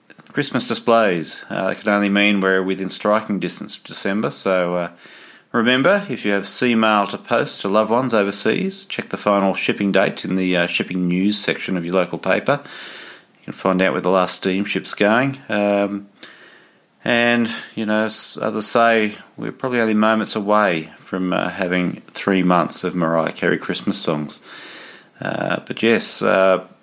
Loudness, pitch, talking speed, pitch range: -19 LUFS, 100 Hz, 170 wpm, 95-110 Hz